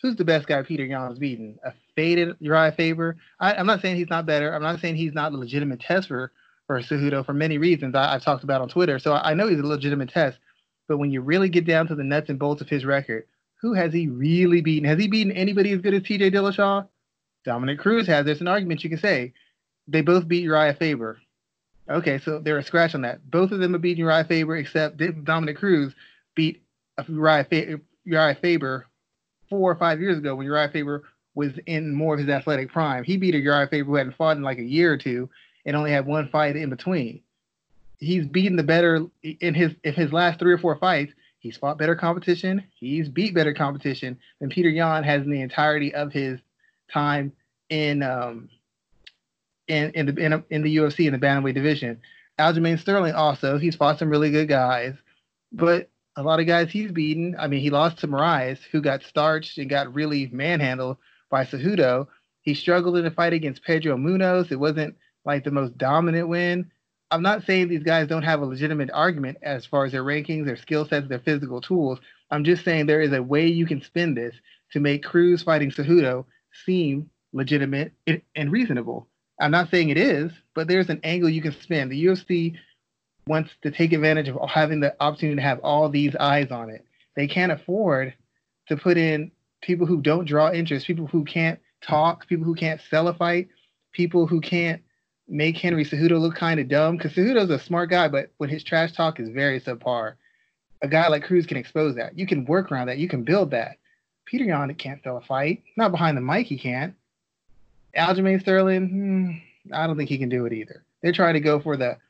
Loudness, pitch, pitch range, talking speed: -23 LUFS, 155 Hz, 140-170 Hz, 215 wpm